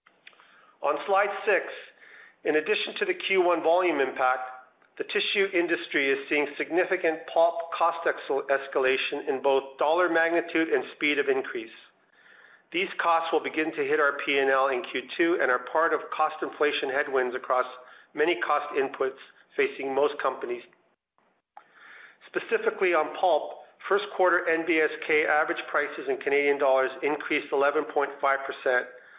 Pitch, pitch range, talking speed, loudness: 165 Hz, 140-200 Hz, 135 wpm, -26 LUFS